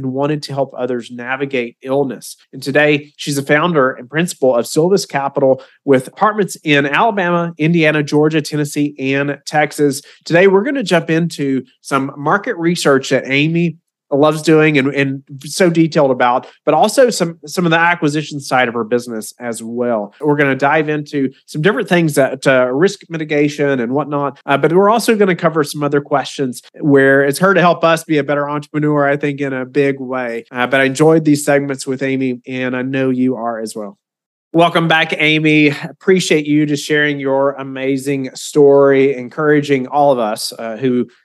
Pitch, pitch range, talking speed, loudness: 145 Hz, 135-155 Hz, 190 wpm, -14 LUFS